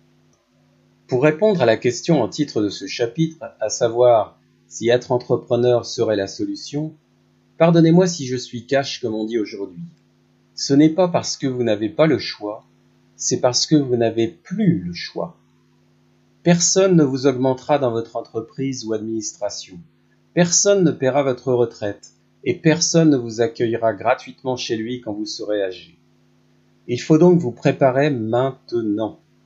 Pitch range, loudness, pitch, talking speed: 105-150 Hz, -19 LUFS, 120 Hz, 155 wpm